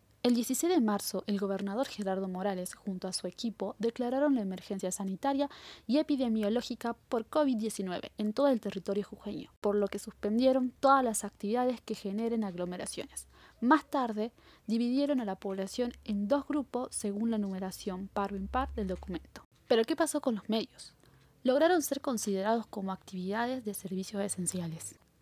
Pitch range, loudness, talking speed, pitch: 200-255 Hz, -33 LUFS, 160 wpm, 220 Hz